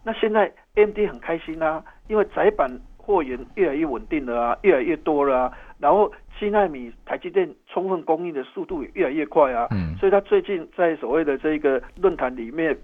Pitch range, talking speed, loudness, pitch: 145-225 Hz, 305 characters per minute, -23 LUFS, 185 Hz